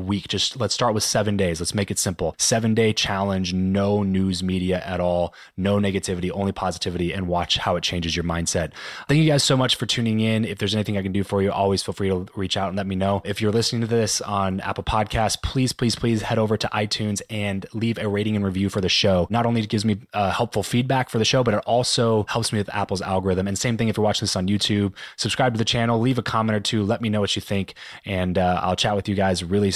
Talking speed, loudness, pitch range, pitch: 265 wpm, -22 LUFS, 95-115 Hz, 100 Hz